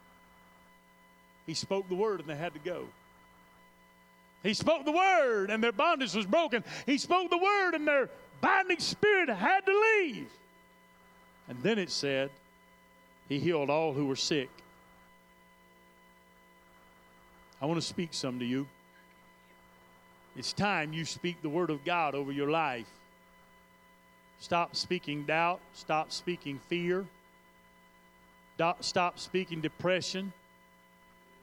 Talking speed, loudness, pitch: 125 wpm, -31 LUFS, 140 Hz